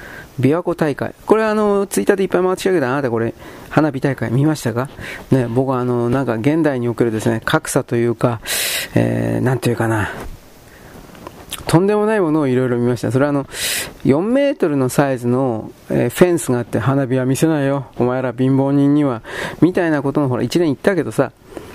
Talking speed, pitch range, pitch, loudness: 400 characters per minute, 120-155 Hz, 135 Hz, -17 LUFS